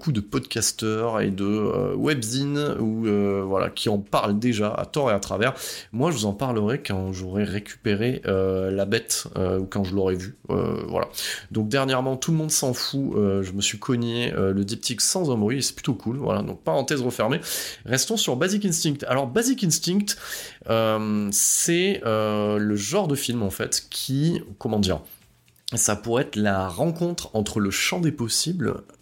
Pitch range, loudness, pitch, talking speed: 100-135 Hz, -24 LUFS, 110 Hz, 190 wpm